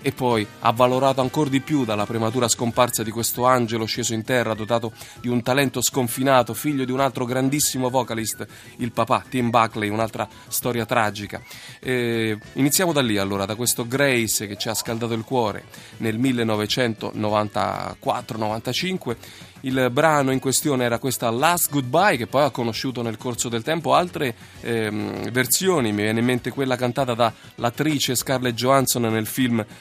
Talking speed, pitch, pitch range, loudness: 160 wpm, 120 Hz, 110-130 Hz, -22 LUFS